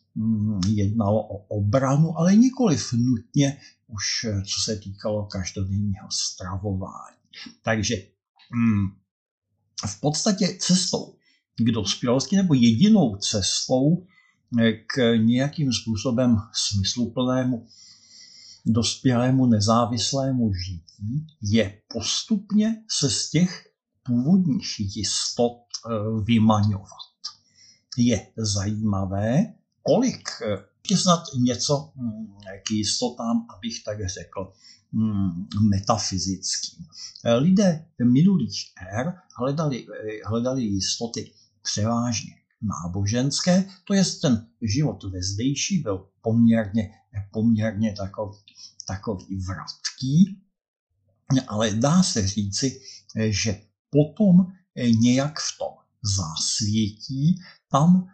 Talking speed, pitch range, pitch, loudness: 85 wpm, 105-140 Hz, 115 Hz, -23 LUFS